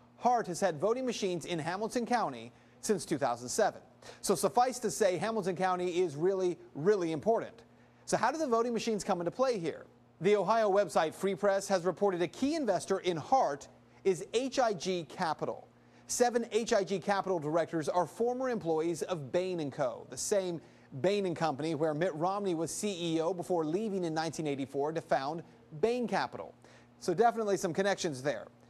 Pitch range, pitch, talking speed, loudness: 165-215 Hz, 190 Hz, 160 wpm, -32 LUFS